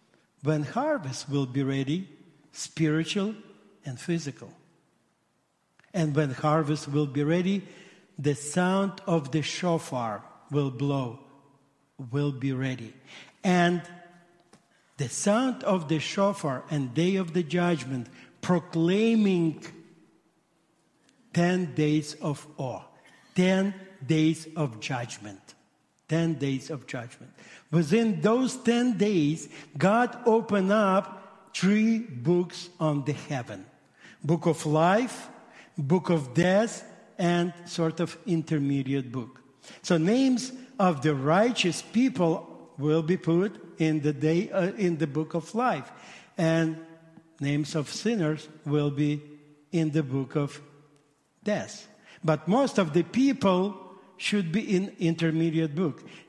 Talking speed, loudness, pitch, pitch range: 115 wpm, -27 LUFS, 165 Hz, 150-190 Hz